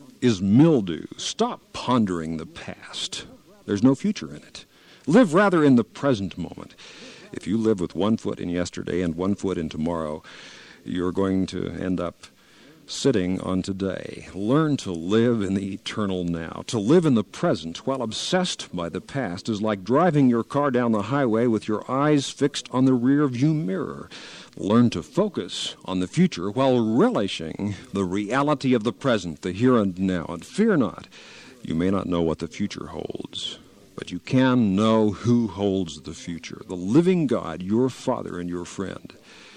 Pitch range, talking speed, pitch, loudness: 90-130 Hz, 175 wpm, 105 Hz, -23 LUFS